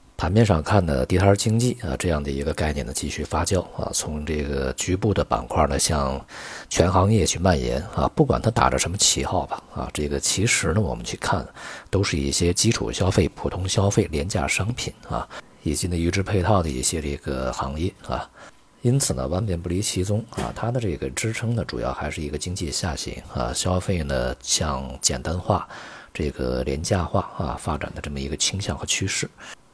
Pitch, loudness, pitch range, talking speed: 85 Hz, -23 LUFS, 70-100 Hz, 295 characters per minute